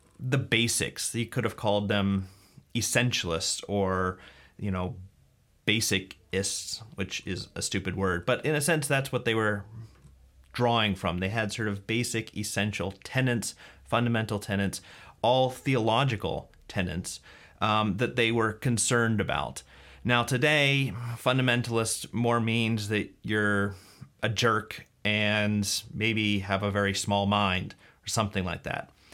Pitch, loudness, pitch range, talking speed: 105 Hz, -28 LUFS, 95-115 Hz, 135 wpm